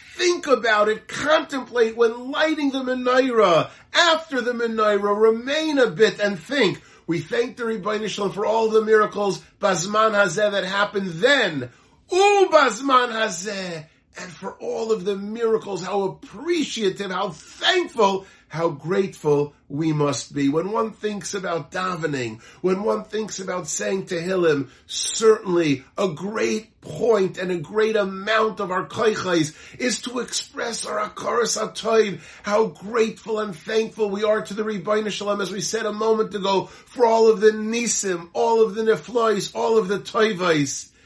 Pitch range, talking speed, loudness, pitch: 190-225 Hz, 155 wpm, -22 LUFS, 215 Hz